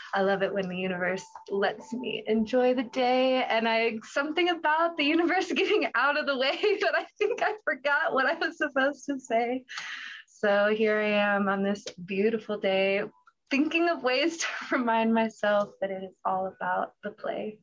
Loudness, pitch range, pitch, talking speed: -27 LUFS, 205-300 Hz, 230 Hz, 185 wpm